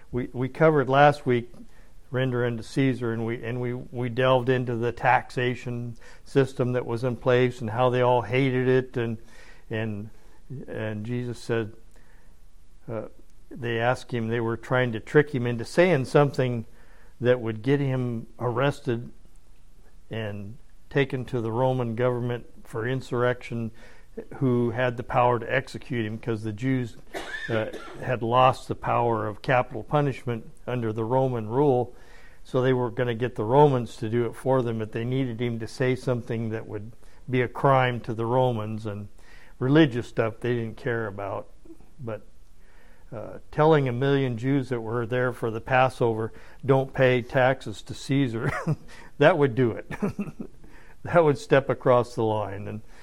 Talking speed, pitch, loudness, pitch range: 165 wpm, 125 Hz, -25 LUFS, 115-130 Hz